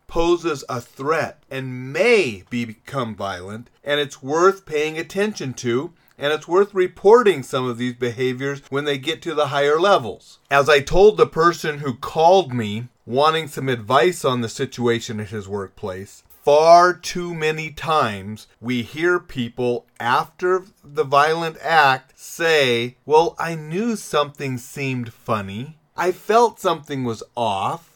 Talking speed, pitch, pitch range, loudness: 150 wpm, 145 Hz, 120-165 Hz, -20 LUFS